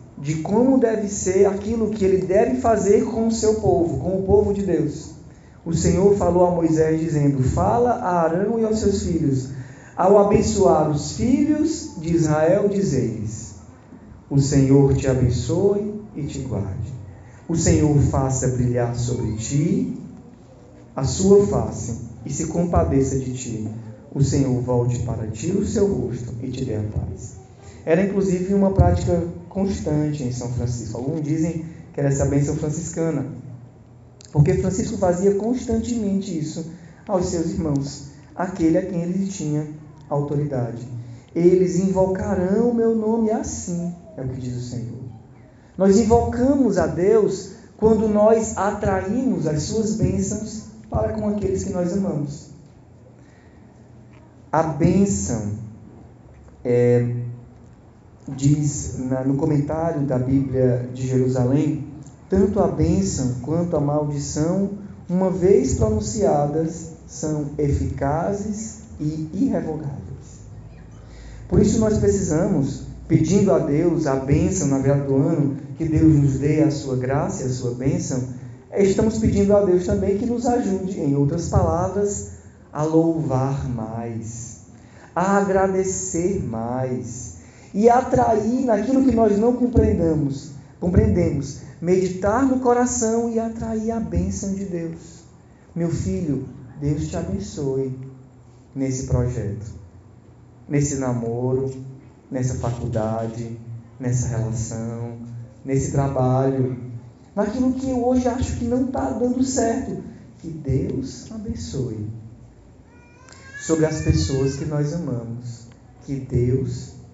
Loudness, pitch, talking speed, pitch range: -21 LUFS, 145 Hz, 125 wpm, 125-190 Hz